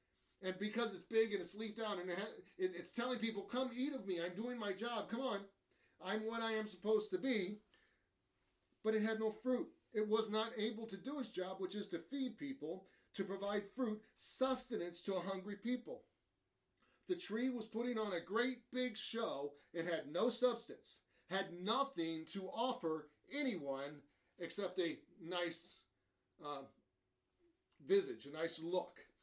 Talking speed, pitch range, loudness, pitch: 165 wpm, 175-235 Hz, -42 LUFS, 210 Hz